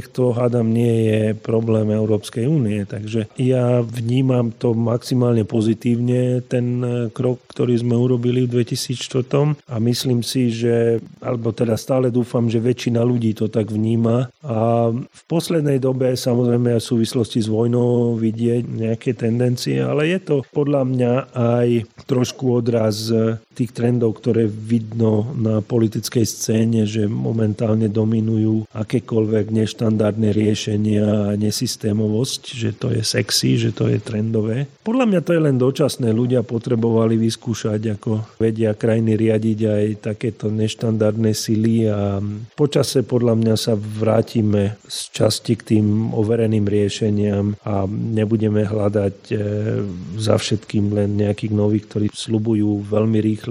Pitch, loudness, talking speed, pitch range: 115 Hz, -19 LUFS, 130 wpm, 110-125 Hz